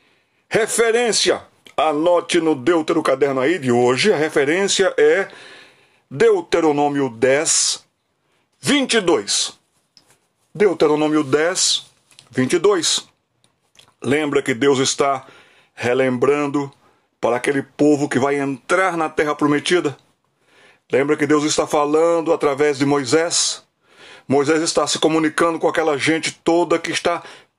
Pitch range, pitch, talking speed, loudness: 140-170 Hz, 155 Hz, 105 wpm, -18 LUFS